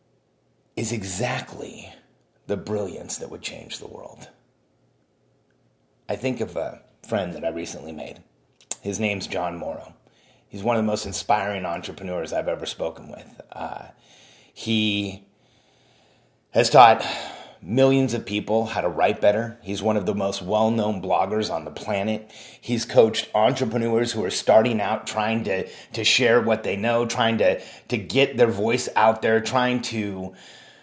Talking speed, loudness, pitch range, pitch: 155 wpm, -23 LUFS, 95-115 Hz, 110 Hz